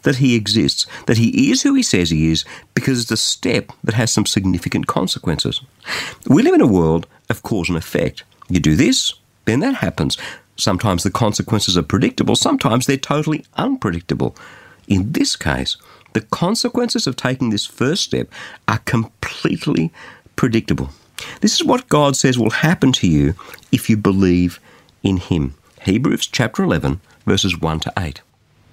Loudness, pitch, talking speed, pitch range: -17 LUFS, 110 Hz, 165 wpm, 90-135 Hz